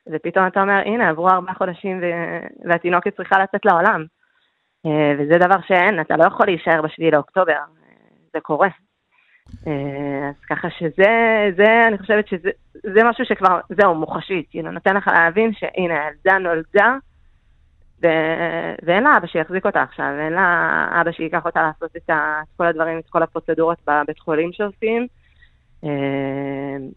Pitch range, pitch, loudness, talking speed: 160-200 Hz, 170 Hz, -18 LUFS, 150 wpm